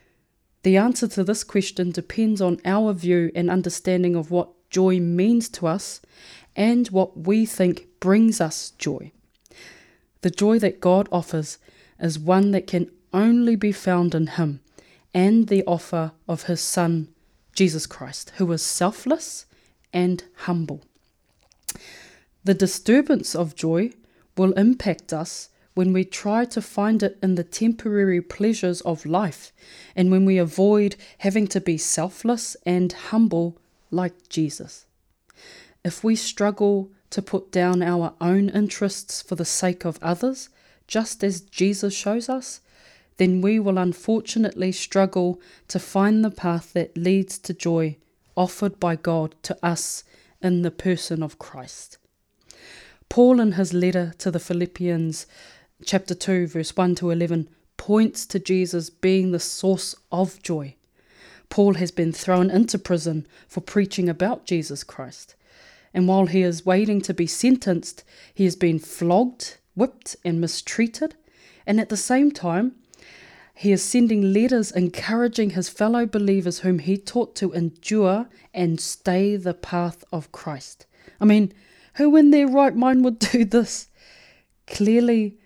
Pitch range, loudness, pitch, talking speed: 175-210 Hz, -22 LUFS, 185 Hz, 145 wpm